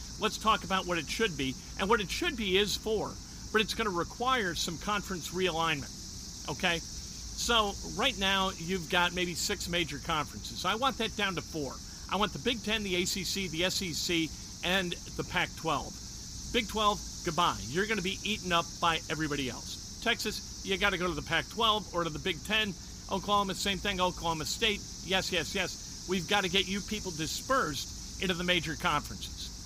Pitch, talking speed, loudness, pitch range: 185 Hz, 190 wpm, -31 LUFS, 170-205 Hz